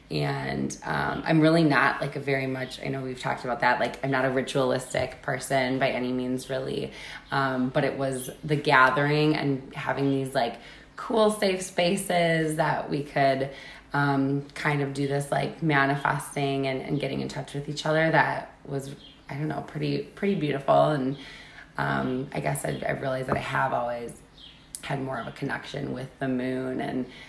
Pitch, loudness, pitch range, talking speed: 140 Hz, -27 LUFS, 130-150 Hz, 185 wpm